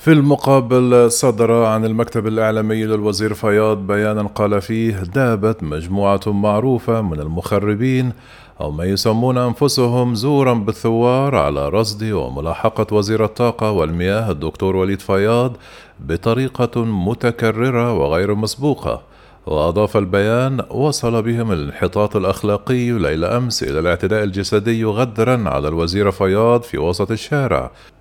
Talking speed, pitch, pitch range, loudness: 115 wpm, 110 Hz, 100-120 Hz, -17 LUFS